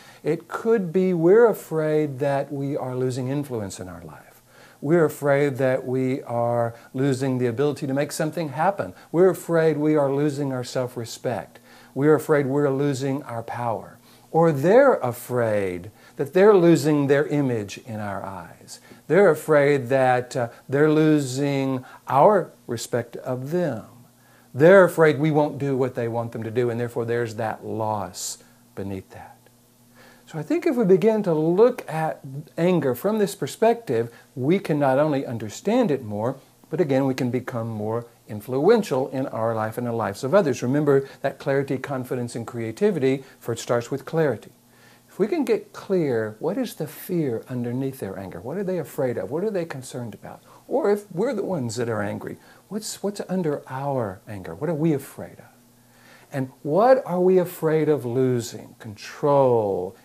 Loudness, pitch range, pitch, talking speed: -23 LUFS, 120-155 Hz, 135 Hz, 170 wpm